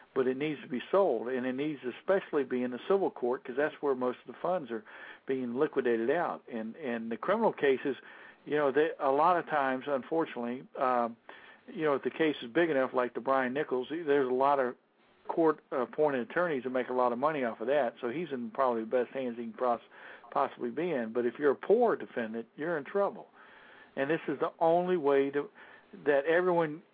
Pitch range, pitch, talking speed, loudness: 125-155 Hz, 130 Hz, 225 wpm, -31 LUFS